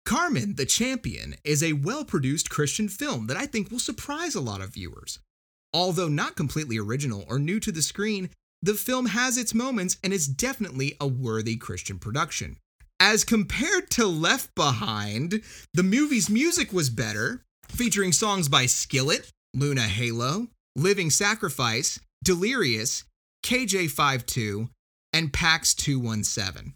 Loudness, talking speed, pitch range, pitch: -25 LUFS, 140 wpm, 130-215 Hz, 170 Hz